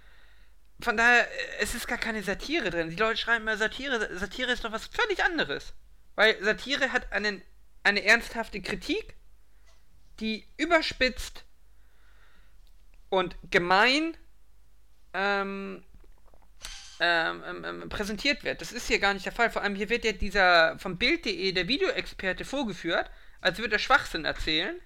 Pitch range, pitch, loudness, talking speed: 195-260 Hz, 220 Hz, -27 LUFS, 140 wpm